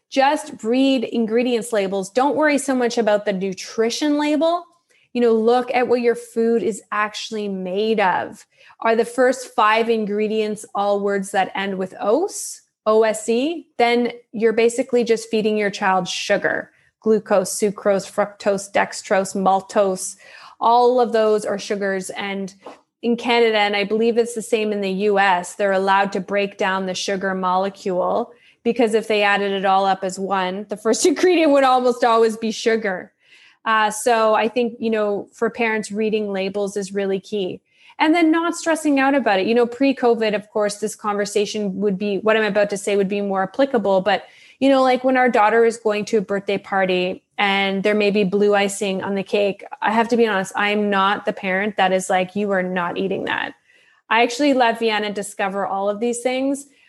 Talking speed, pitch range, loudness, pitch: 185 wpm, 200-240 Hz, -19 LUFS, 215 Hz